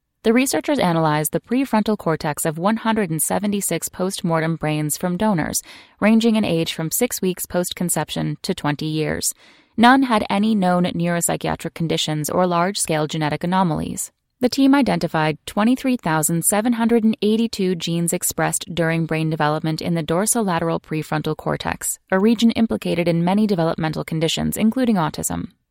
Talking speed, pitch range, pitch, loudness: 135 wpm, 160-215 Hz, 175 Hz, -20 LUFS